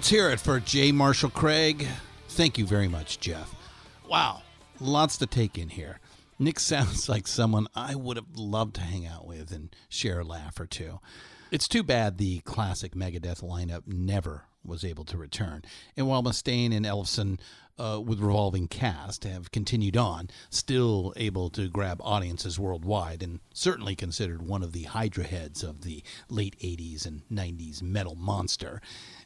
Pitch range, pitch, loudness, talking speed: 90-115 Hz, 100 Hz, -29 LUFS, 170 wpm